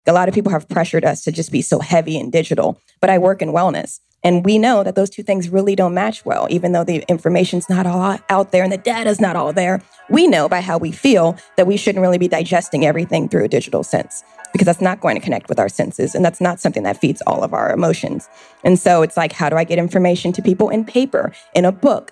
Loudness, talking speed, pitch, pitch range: -16 LUFS, 260 wpm, 180 Hz, 165-195 Hz